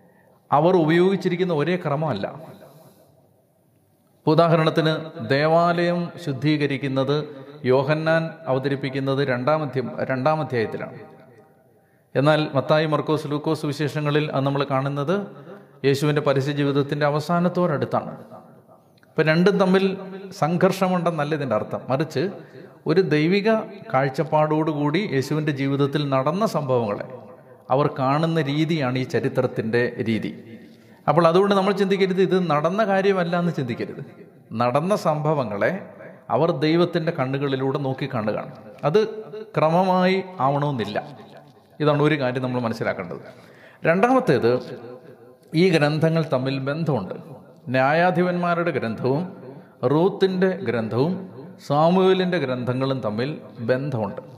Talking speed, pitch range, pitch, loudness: 90 wpm, 130-175 Hz, 150 Hz, -22 LUFS